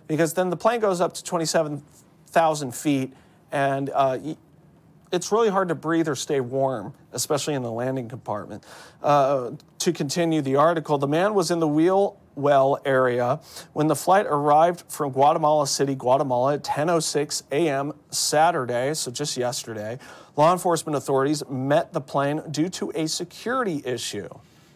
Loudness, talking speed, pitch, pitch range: -23 LUFS, 155 wpm, 150 Hz, 135-165 Hz